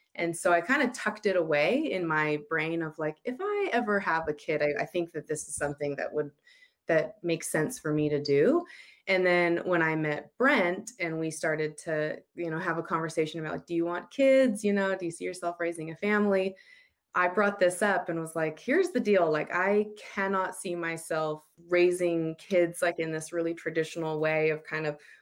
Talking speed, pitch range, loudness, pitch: 215 wpm, 155-190 Hz, -29 LUFS, 170 Hz